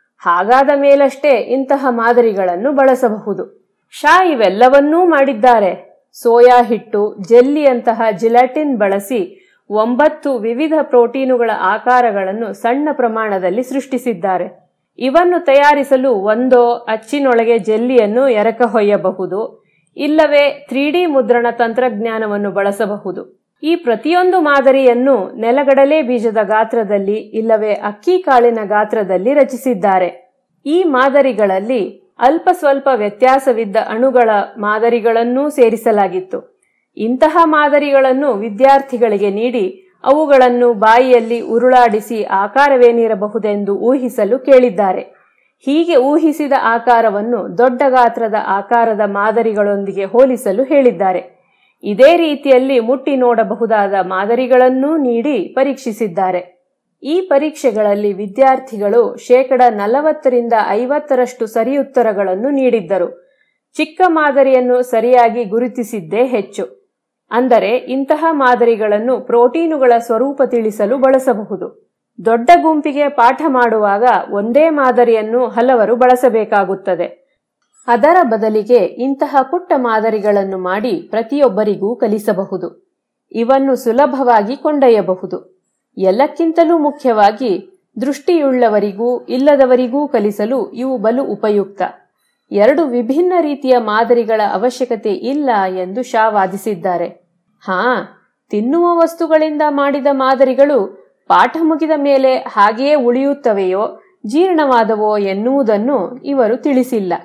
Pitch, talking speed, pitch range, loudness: 245 Hz, 85 wpm, 220-275 Hz, -13 LUFS